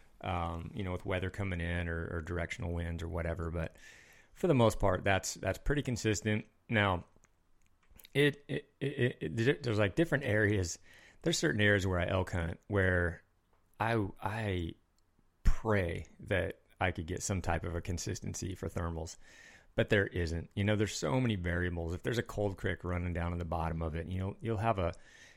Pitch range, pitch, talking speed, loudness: 85-110 Hz, 95 Hz, 190 wpm, -34 LUFS